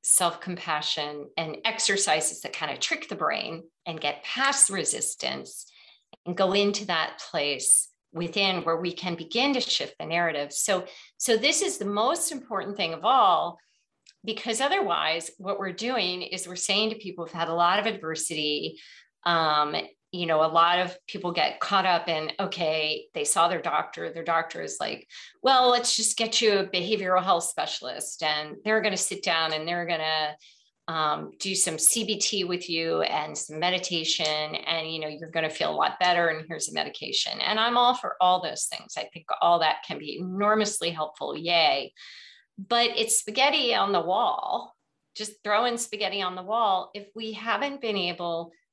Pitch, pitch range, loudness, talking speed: 180 Hz, 165-220 Hz, -25 LUFS, 185 wpm